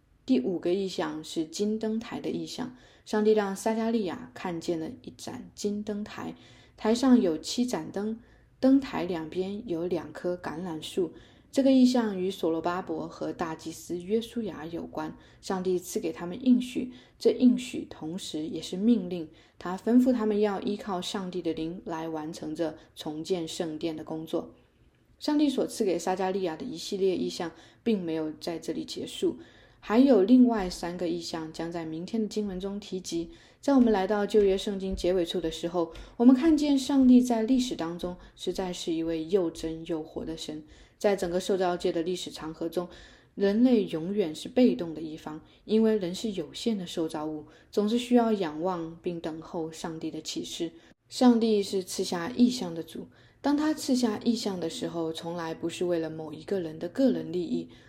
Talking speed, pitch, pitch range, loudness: 265 characters per minute, 180 Hz, 165-220 Hz, -29 LUFS